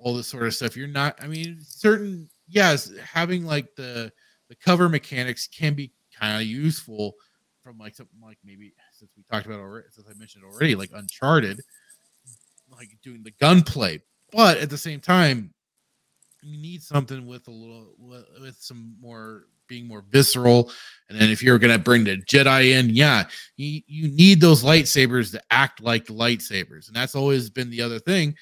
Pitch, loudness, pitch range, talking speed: 125 Hz, -20 LUFS, 115-150 Hz, 180 wpm